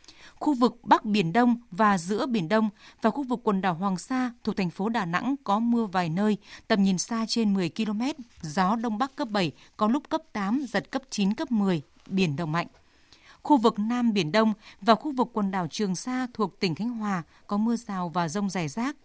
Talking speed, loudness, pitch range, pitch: 225 wpm, -27 LUFS, 195-240 Hz, 215 Hz